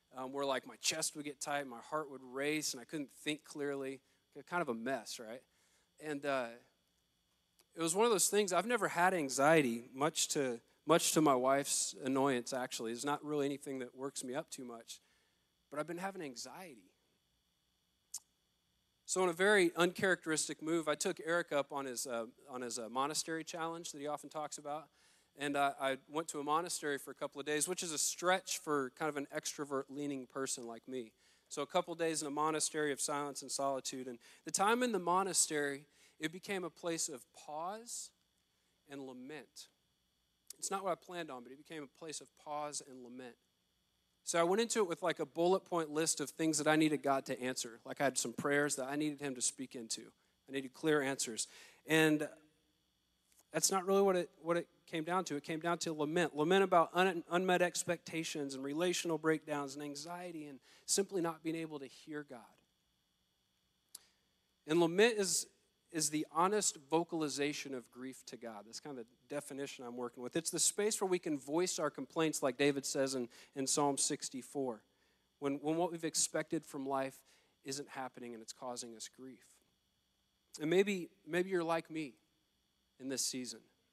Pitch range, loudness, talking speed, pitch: 135-165 Hz, -37 LUFS, 195 wpm, 150 Hz